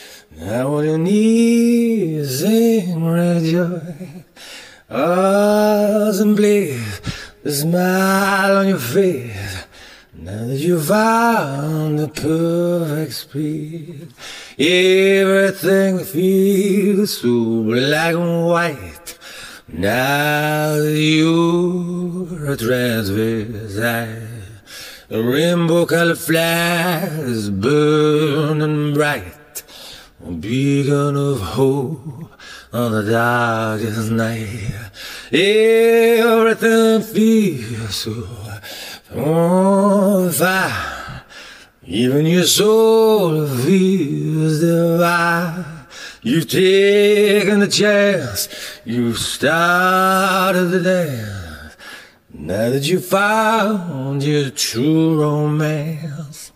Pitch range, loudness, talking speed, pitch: 130-190 Hz, -16 LUFS, 75 wpm, 160 Hz